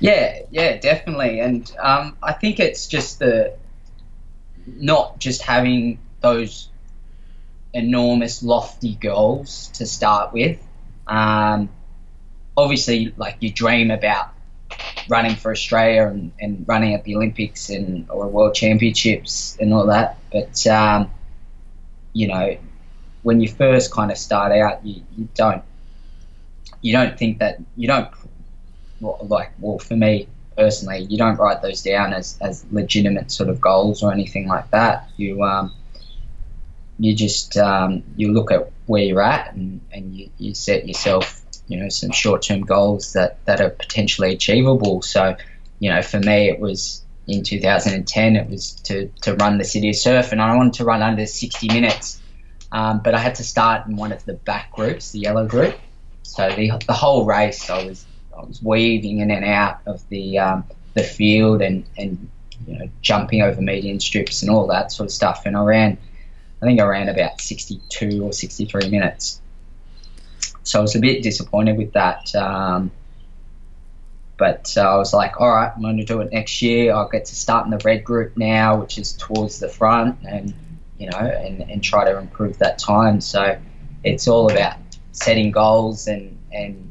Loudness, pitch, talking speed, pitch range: -18 LUFS, 105 Hz, 175 wpm, 100-115 Hz